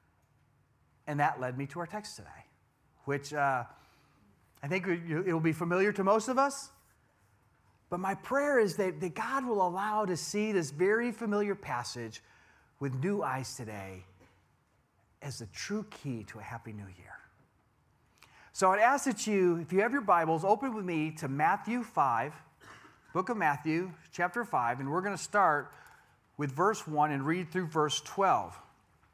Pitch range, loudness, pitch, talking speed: 135-205 Hz, -31 LUFS, 170 Hz, 165 wpm